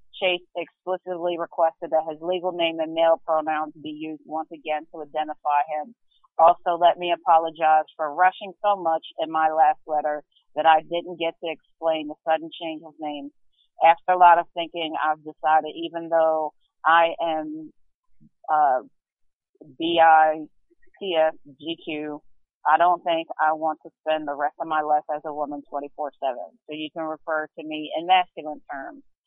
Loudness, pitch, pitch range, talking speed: -23 LUFS, 160 Hz, 155-170 Hz, 170 wpm